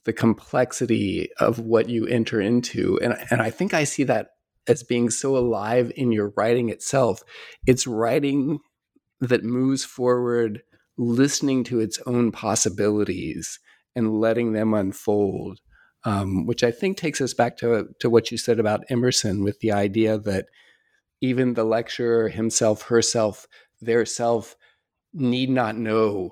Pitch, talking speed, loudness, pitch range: 115 Hz, 145 wpm, -23 LUFS, 110-125 Hz